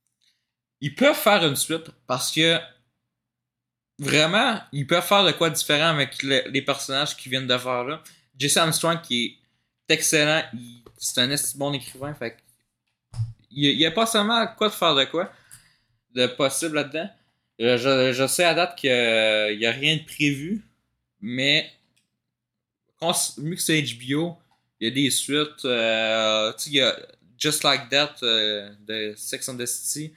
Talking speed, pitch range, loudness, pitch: 165 wpm, 120-160 Hz, -22 LUFS, 140 Hz